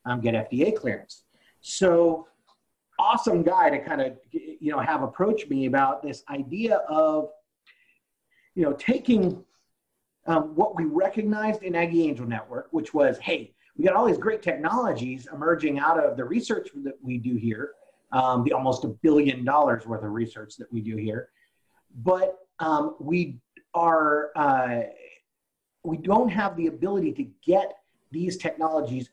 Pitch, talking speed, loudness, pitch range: 160 Hz, 155 wpm, -25 LUFS, 130-195 Hz